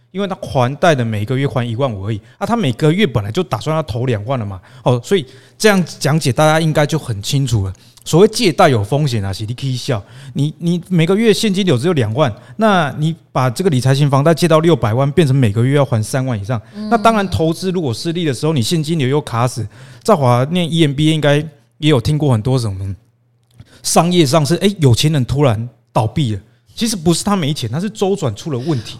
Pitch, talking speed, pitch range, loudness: 140 Hz, 335 characters per minute, 120-165 Hz, -15 LUFS